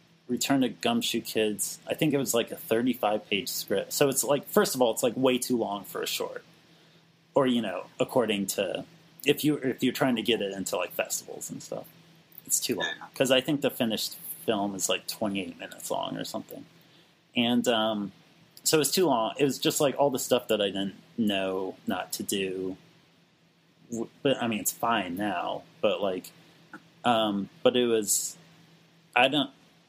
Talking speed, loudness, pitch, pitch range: 190 wpm, -28 LUFS, 125 Hz, 105-155 Hz